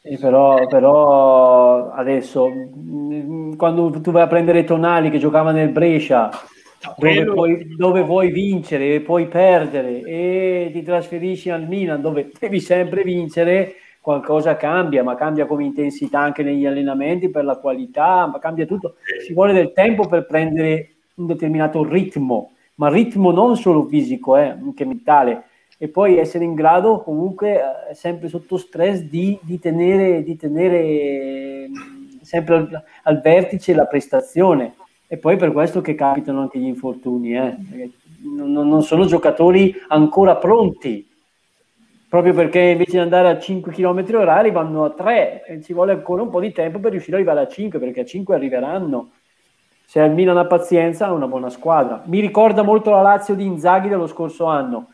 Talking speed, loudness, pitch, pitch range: 160 wpm, -16 LUFS, 170 Hz, 150-185 Hz